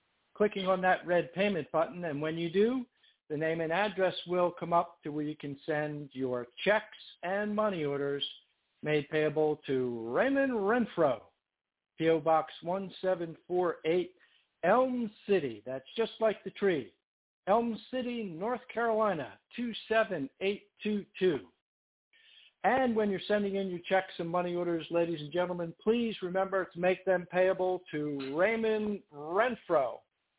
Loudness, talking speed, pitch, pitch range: -32 LUFS, 135 wpm, 185 Hz, 160-210 Hz